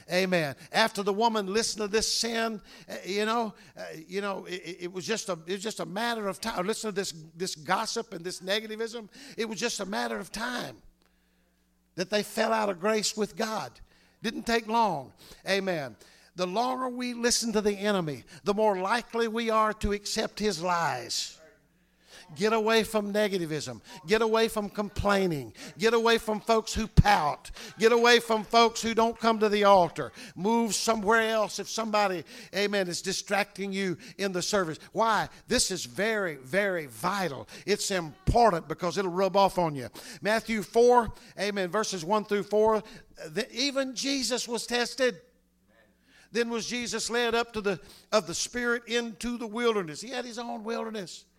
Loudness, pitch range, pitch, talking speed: -28 LUFS, 185-230 Hz, 210 Hz, 175 wpm